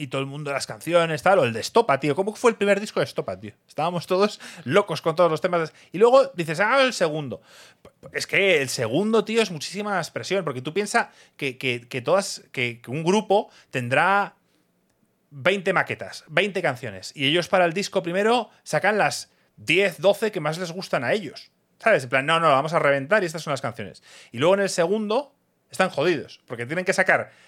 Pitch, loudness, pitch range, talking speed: 180 Hz, -23 LUFS, 145-200 Hz, 210 wpm